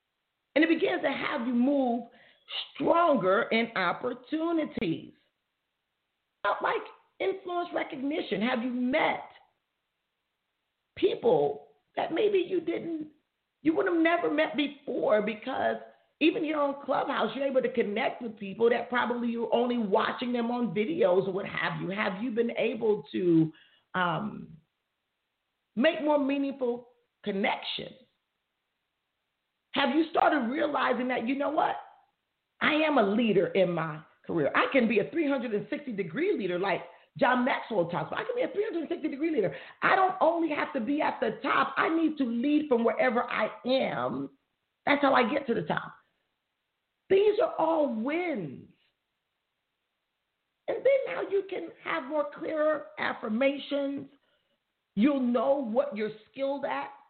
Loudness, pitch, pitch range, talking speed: -28 LUFS, 275 Hz, 235-315 Hz, 145 wpm